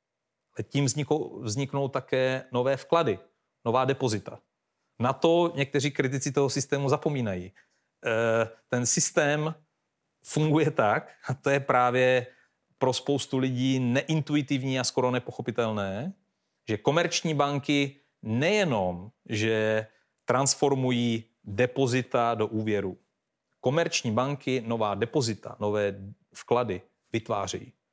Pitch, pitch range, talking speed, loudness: 130 Hz, 115-140 Hz, 100 wpm, -27 LUFS